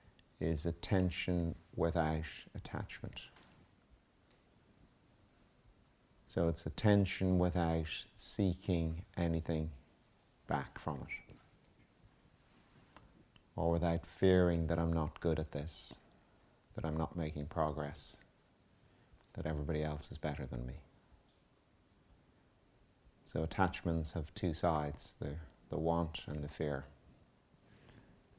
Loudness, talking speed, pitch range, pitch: -38 LUFS, 95 wpm, 75-85 Hz, 80 Hz